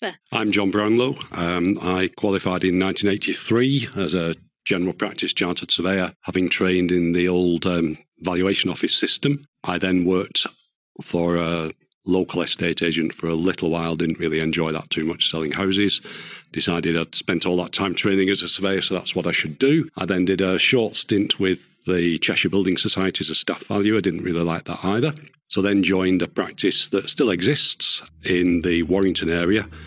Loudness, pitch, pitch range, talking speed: -21 LUFS, 90 Hz, 85-100 Hz, 185 wpm